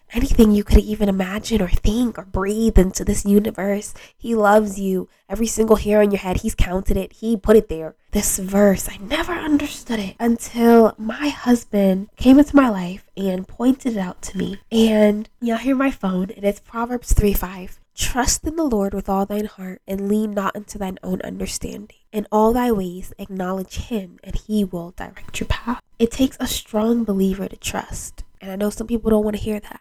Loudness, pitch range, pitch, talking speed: -20 LUFS, 195-230 Hz, 210 Hz, 205 wpm